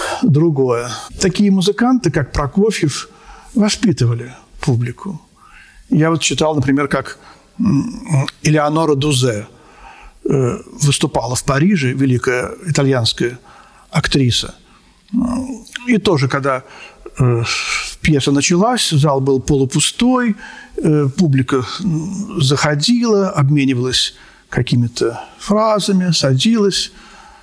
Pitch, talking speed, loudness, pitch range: 150 Hz, 75 wpm, -16 LUFS, 135-195 Hz